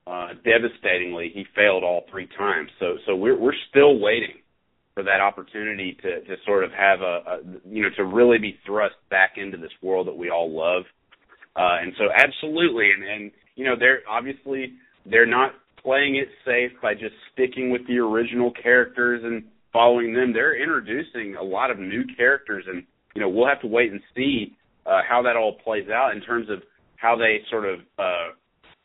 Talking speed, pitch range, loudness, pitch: 190 wpm, 100-130 Hz, -21 LUFS, 115 Hz